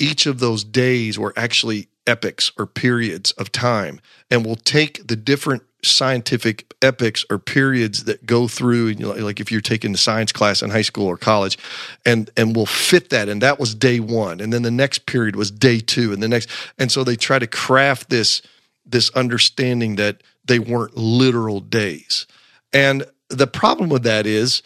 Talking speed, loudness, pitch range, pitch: 190 wpm, -18 LUFS, 110-130 Hz, 120 Hz